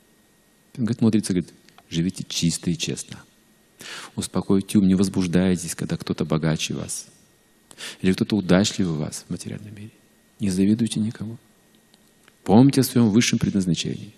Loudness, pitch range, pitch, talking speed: -22 LUFS, 90-110 Hz, 100 Hz, 125 wpm